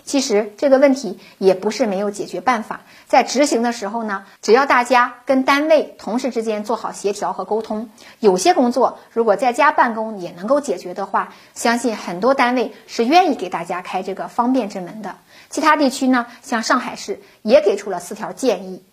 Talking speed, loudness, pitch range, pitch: 300 characters per minute, -18 LUFS, 200-260 Hz, 230 Hz